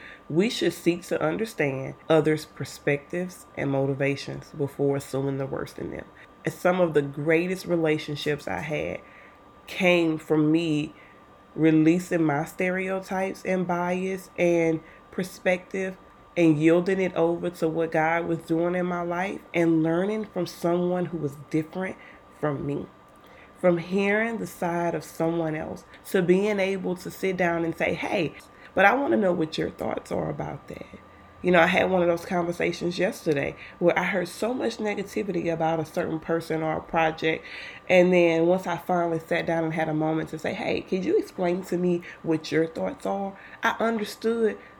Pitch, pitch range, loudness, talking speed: 170 Hz, 155-185 Hz, -26 LUFS, 170 wpm